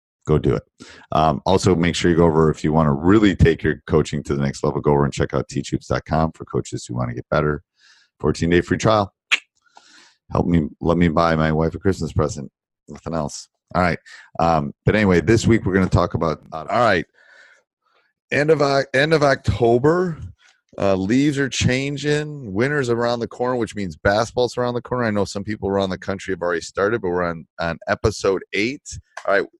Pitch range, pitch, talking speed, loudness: 80-120 Hz, 95 Hz, 210 wpm, -20 LUFS